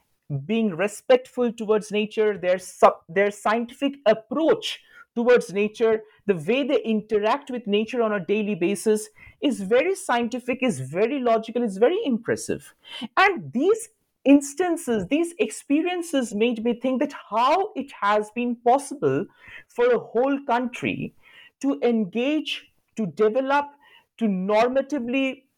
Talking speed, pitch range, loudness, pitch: 125 wpm, 215-285 Hz, -23 LUFS, 240 Hz